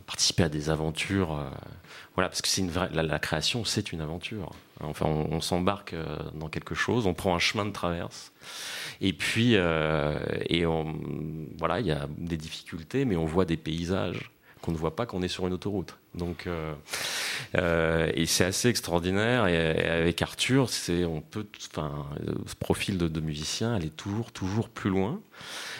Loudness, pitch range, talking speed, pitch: -29 LUFS, 80-100 Hz, 185 wpm, 85 Hz